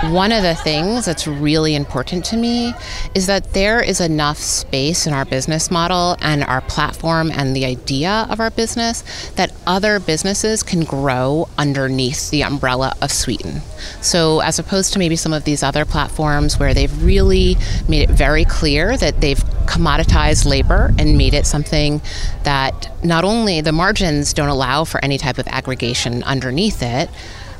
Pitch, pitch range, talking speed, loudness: 150 Hz, 130-175 Hz, 165 wpm, -17 LUFS